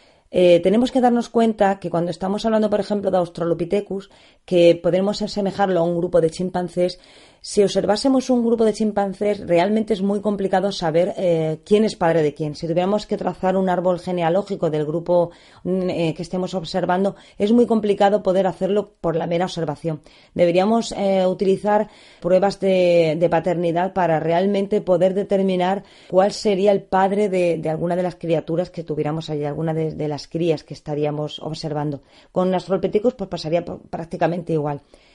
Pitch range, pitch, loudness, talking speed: 170-200 Hz, 185 Hz, -20 LUFS, 170 wpm